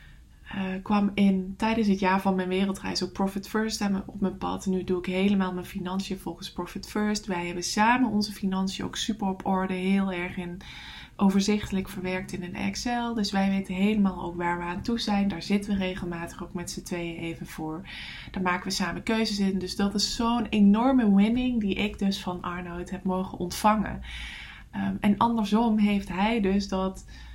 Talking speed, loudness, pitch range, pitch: 195 wpm, -27 LUFS, 185-210 Hz, 195 Hz